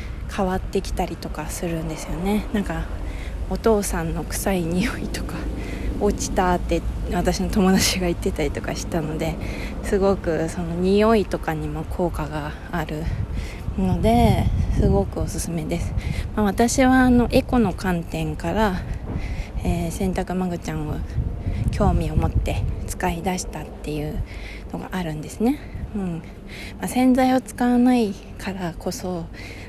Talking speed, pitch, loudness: 280 characters per minute, 175 Hz, -23 LUFS